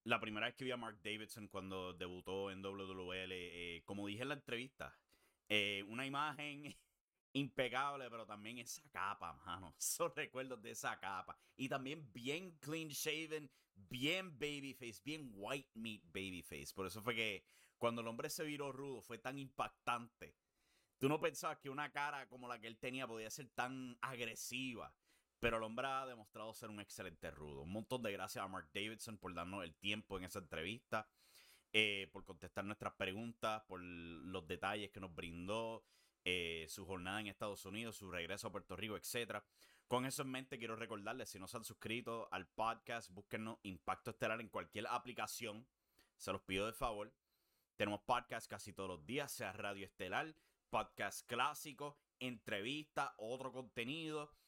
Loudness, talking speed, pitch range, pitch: -45 LUFS, 170 wpm, 100-130 Hz, 115 Hz